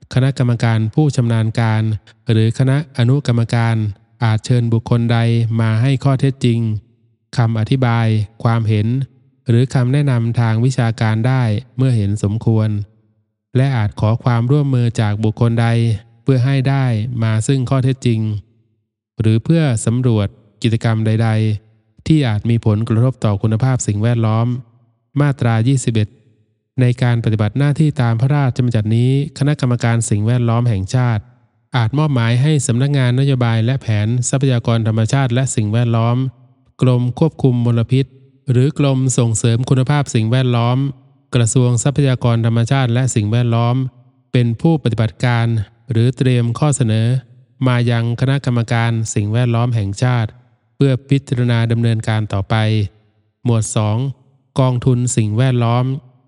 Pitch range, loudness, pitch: 115-130 Hz, -16 LUFS, 120 Hz